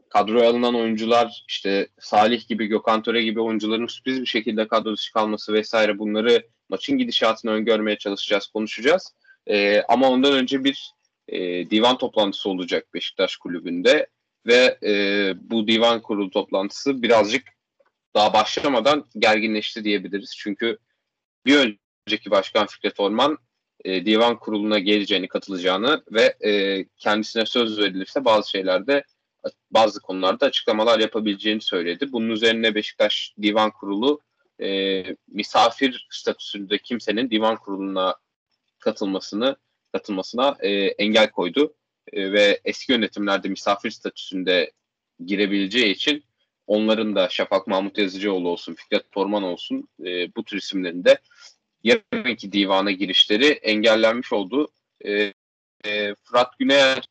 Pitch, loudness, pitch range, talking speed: 110 Hz, -21 LUFS, 100-120 Hz, 120 wpm